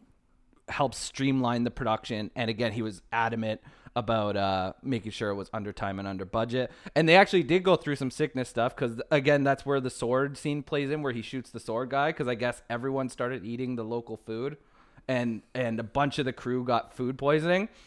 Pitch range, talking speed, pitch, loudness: 115-140 Hz, 210 wpm, 125 Hz, -29 LUFS